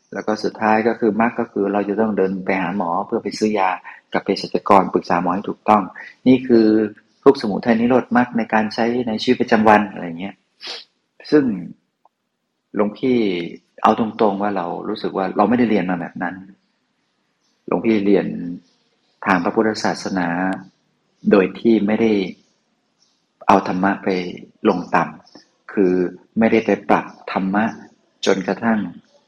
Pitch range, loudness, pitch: 95-115 Hz, -19 LUFS, 105 Hz